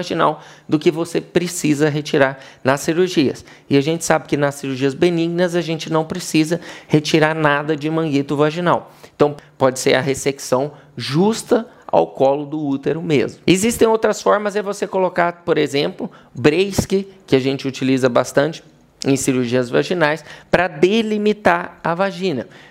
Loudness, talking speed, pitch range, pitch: -18 LUFS, 150 wpm, 140-180 Hz, 155 Hz